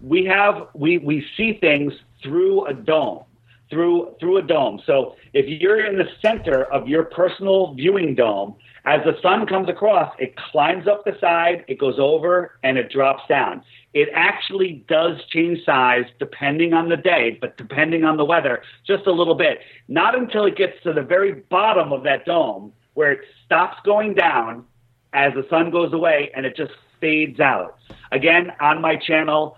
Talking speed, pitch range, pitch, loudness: 180 wpm, 145-195 Hz, 170 Hz, -19 LUFS